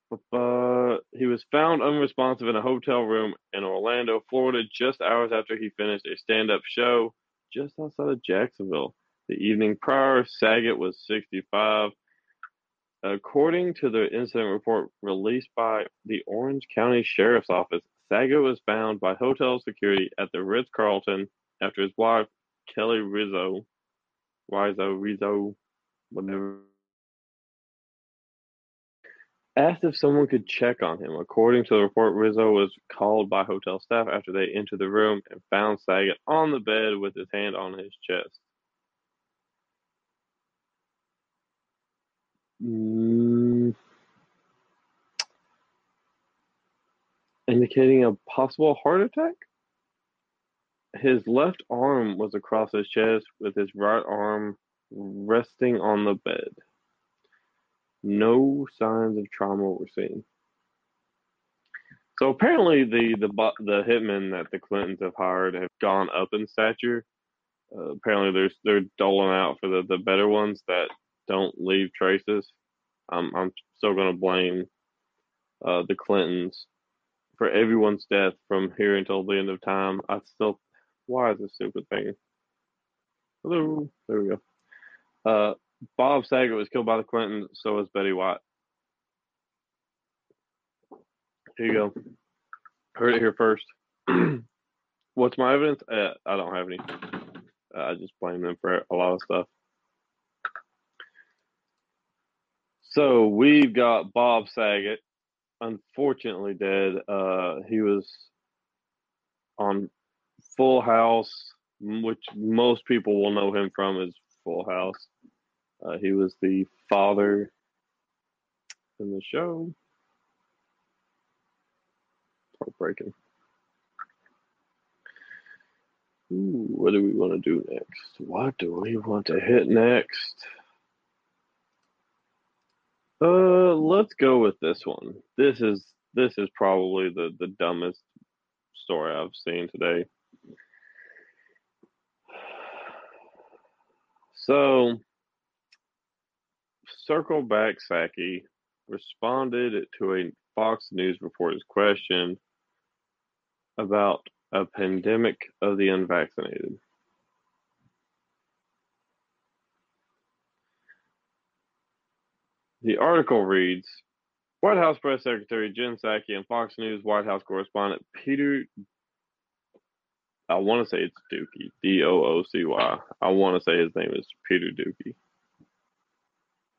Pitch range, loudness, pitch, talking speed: 95-120 Hz, -25 LUFS, 105 Hz, 115 wpm